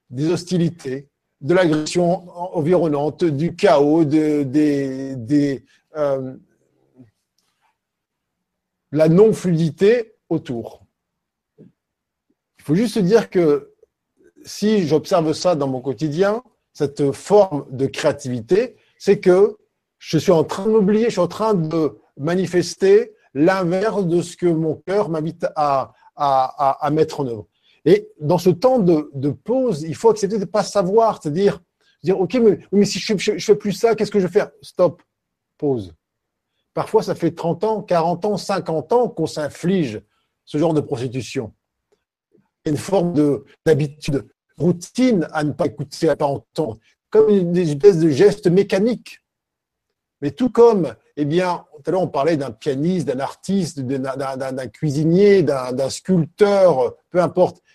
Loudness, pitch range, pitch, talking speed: -19 LUFS, 145-200 Hz, 170 Hz, 155 wpm